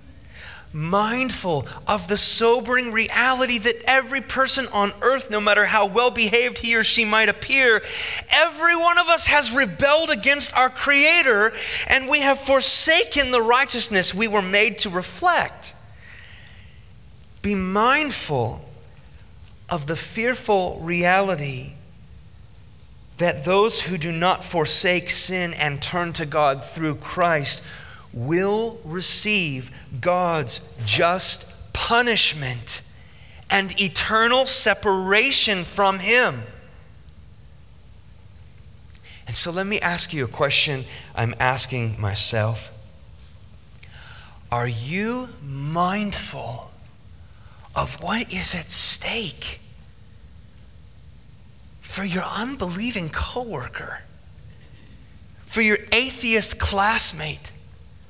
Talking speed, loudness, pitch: 100 wpm, -20 LUFS, 190 Hz